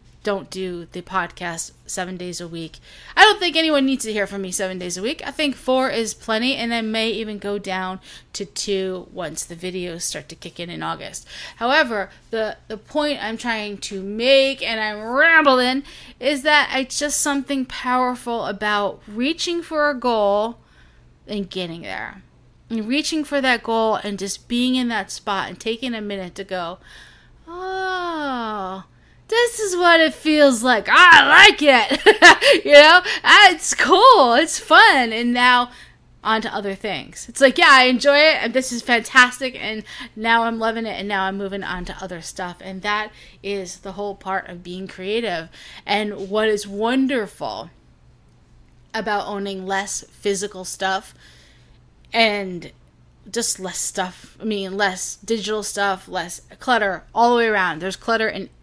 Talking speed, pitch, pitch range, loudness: 170 wpm, 220 Hz, 195-260 Hz, -17 LUFS